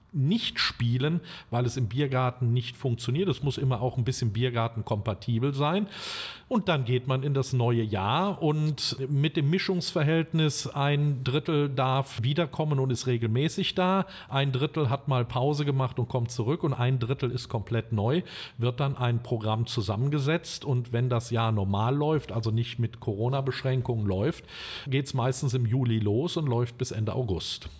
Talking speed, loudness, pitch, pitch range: 170 wpm, -28 LUFS, 130 Hz, 120-150 Hz